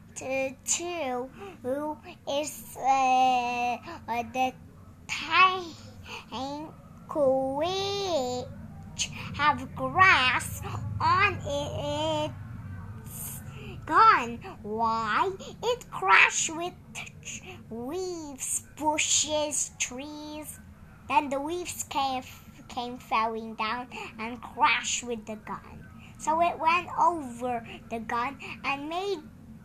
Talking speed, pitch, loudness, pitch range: 85 wpm, 265 Hz, -27 LUFS, 235-315 Hz